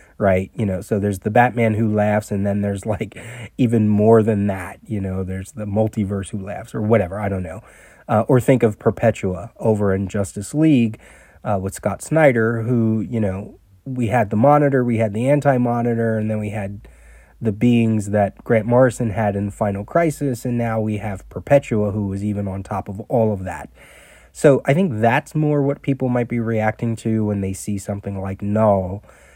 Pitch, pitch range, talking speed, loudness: 110 Hz, 100-120 Hz, 200 wpm, -19 LUFS